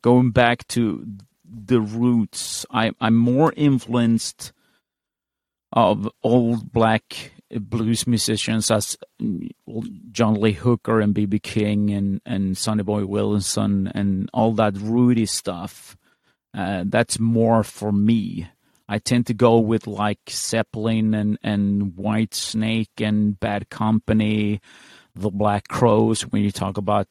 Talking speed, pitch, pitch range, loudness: 125 wpm, 110 Hz, 105-115 Hz, -21 LUFS